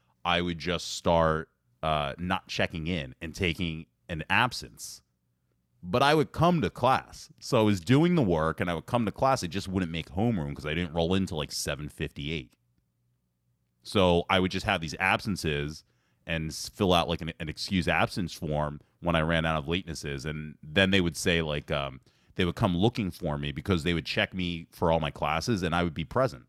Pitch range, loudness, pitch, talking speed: 75-95 Hz, -28 LUFS, 85 Hz, 205 wpm